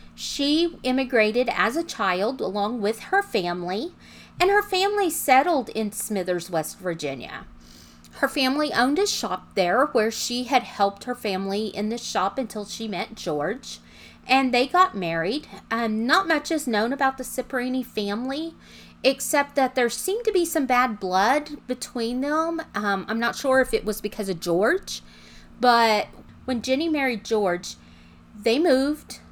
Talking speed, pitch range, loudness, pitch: 160 wpm, 205-275 Hz, -24 LUFS, 240 Hz